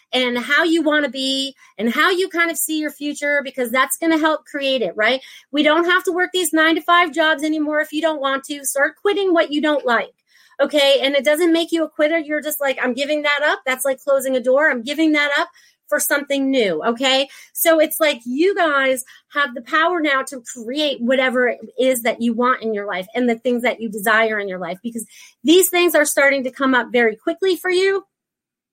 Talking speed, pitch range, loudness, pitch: 235 wpm, 255-315 Hz, -18 LUFS, 285 Hz